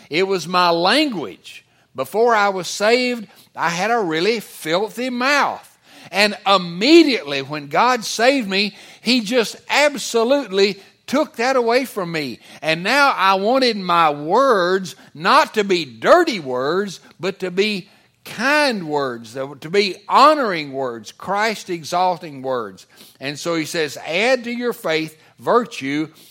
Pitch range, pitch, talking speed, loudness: 160-240 Hz, 195 Hz, 135 wpm, -18 LUFS